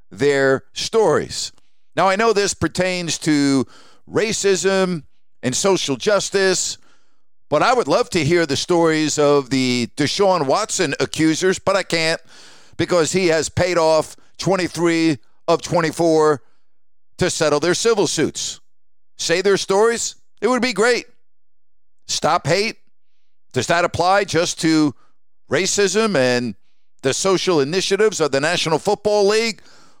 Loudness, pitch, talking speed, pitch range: -18 LUFS, 170 Hz, 130 wpm, 145-195 Hz